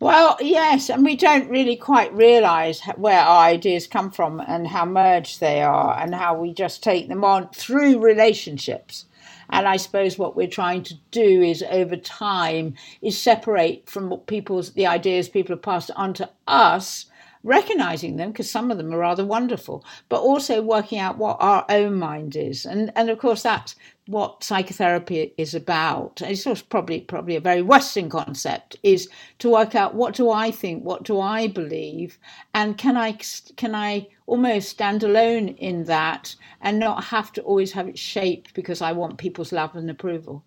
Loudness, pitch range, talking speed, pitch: -20 LUFS, 175-225 Hz, 180 wpm, 195 Hz